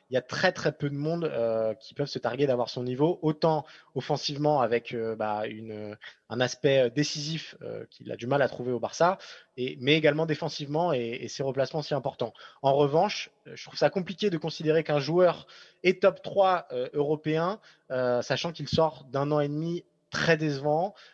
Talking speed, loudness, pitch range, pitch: 195 wpm, -28 LUFS, 125-160 Hz, 150 Hz